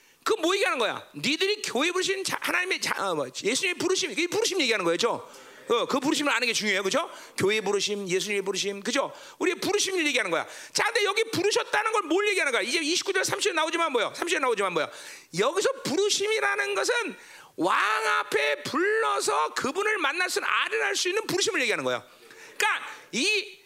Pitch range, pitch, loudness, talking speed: 280-420 Hz, 380 Hz, -26 LUFS, 415 characters per minute